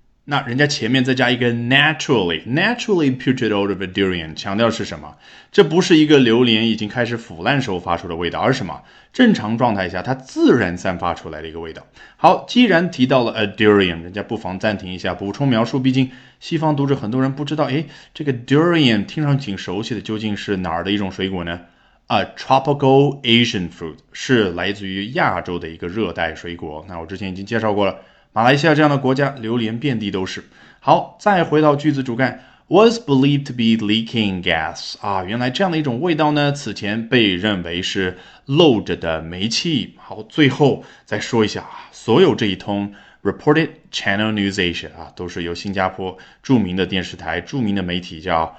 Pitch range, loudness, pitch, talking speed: 95-135 Hz, -18 LUFS, 110 Hz, 405 characters per minute